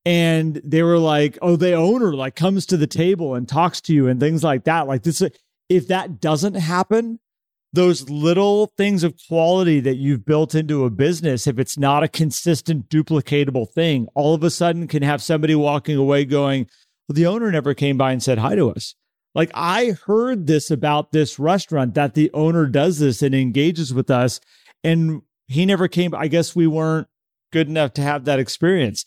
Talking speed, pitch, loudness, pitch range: 195 wpm, 155 Hz, -19 LUFS, 145-170 Hz